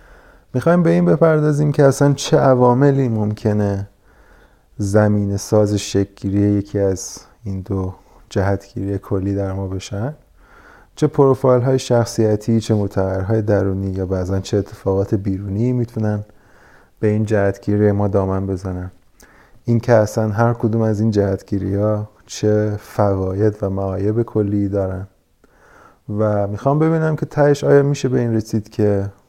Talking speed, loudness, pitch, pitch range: 135 wpm, -18 LUFS, 105 Hz, 100-115 Hz